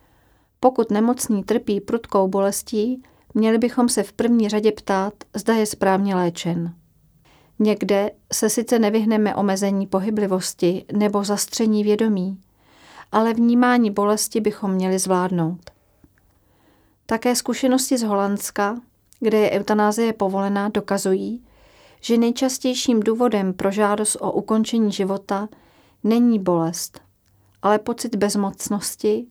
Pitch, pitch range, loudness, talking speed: 210 Hz, 195-225 Hz, -20 LUFS, 110 wpm